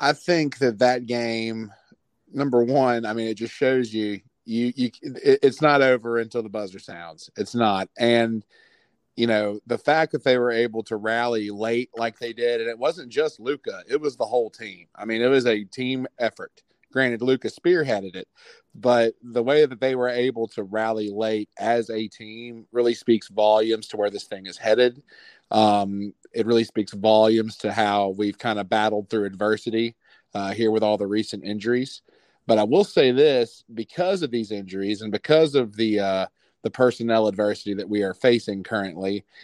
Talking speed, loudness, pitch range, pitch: 190 wpm, -23 LUFS, 105-125 Hz, 115 Hz